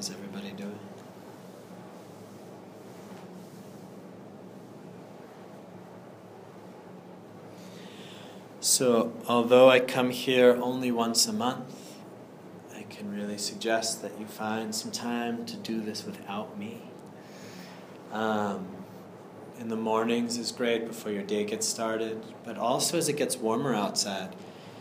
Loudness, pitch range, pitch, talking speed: -28 LUFS, 105-120 Hz, 115 Hz, 105 wpm